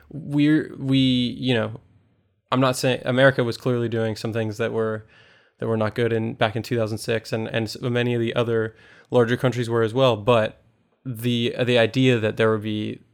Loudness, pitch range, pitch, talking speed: -22 LUFS, 110-125 Hz, 115 Hz, 195 wpm